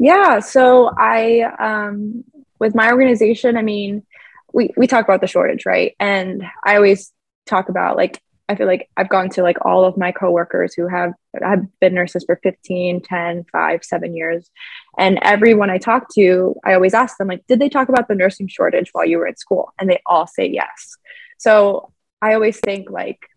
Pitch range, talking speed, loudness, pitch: 185-240 Hz, 195 wpm, -16 LUFS, 200 Hz